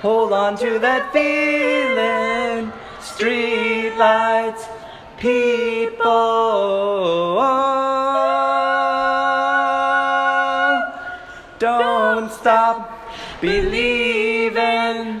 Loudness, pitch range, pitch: -18 LUFS, 200-240 Hz, 230 Hz